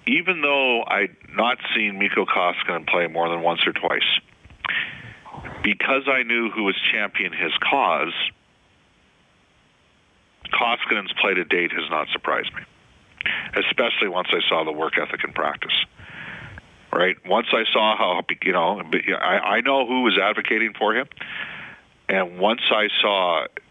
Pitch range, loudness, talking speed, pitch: 85-135 Hz, -21 LUFS, 140 wpm, 115 Hz